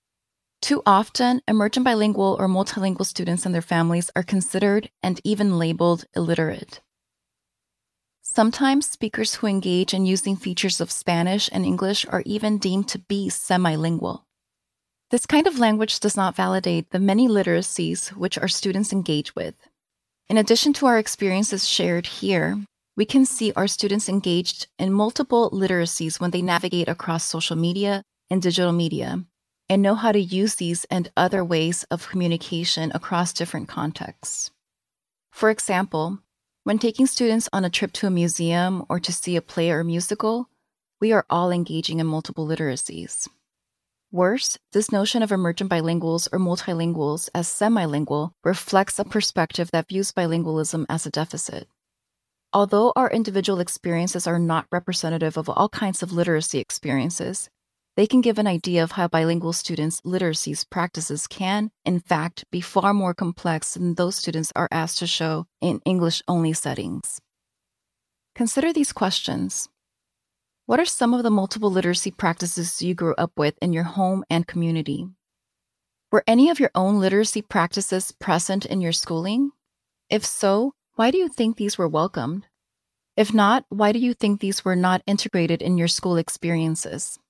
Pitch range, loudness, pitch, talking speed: 170-205 Hz, -22 LUFS, 185 Hz, 155 wpm